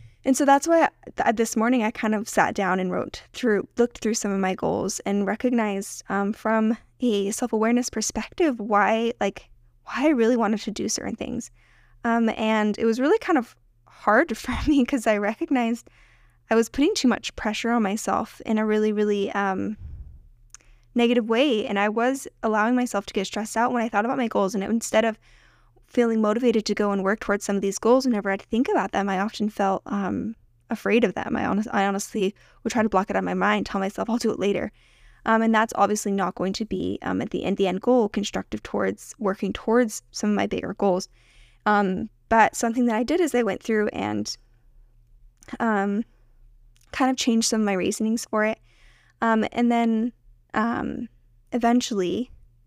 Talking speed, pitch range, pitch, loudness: 205 wpm, 195-235 Hz, 215 Hz, -24 LUFS